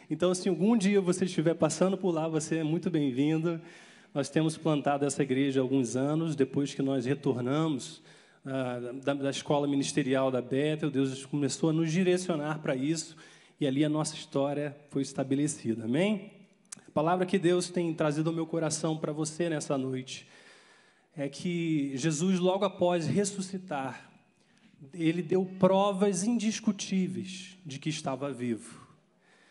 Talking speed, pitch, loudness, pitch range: 155 wpm, 160 Hz, -30 LUFS, 140-185 Hz